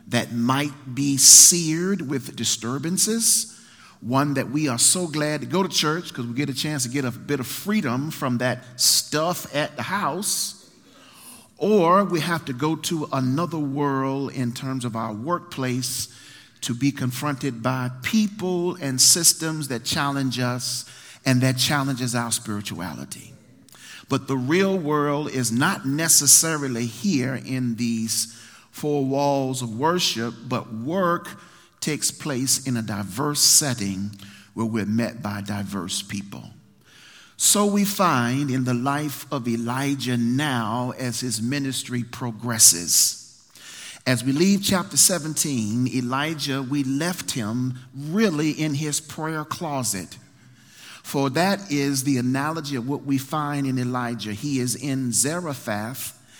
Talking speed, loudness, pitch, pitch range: 140 wpm, -21 LUFS, 135 Hz, 125-150 Hz